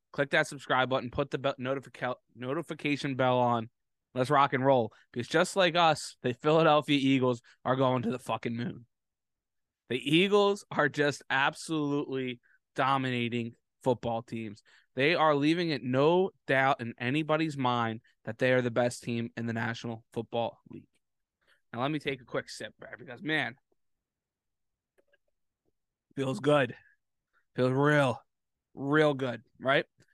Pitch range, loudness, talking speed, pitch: 120-145 Hz, -29 LUFS, 145 wpm, 130 Hz